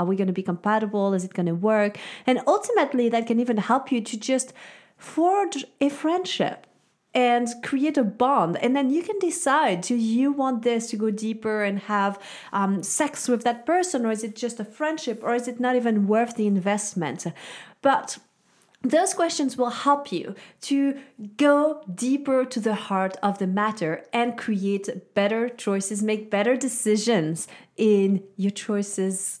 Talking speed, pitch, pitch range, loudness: 175 wpm, 230 Hz, 205-265 Hz, -24 LUFS